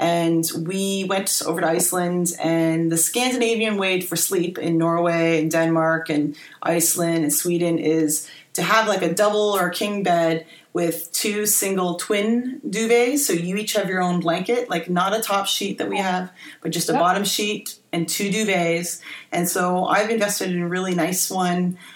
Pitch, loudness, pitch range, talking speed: 180 Hz, -21 LUFS, 165-200 Hz, 180 wpm